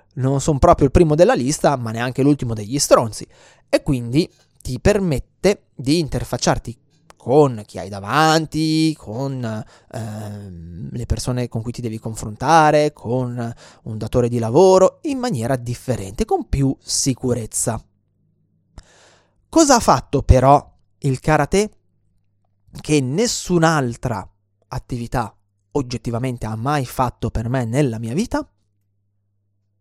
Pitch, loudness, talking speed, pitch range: 125 Hz, -19 LUFS, 120 wpm, 110-150 Hz